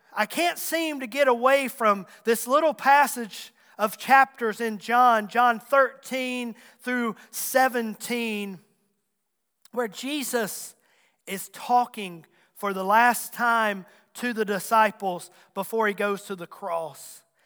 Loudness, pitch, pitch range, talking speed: -24 LUFS, 225 Hz, 205-250 Hz, 120 wpm